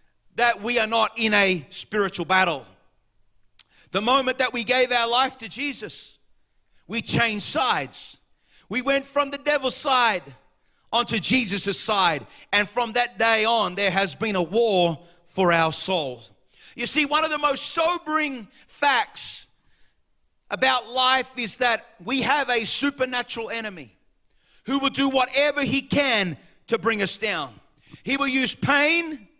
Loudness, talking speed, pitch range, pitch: -22 LUFS, 150 wpm, 190-265 Hz, 230 Hz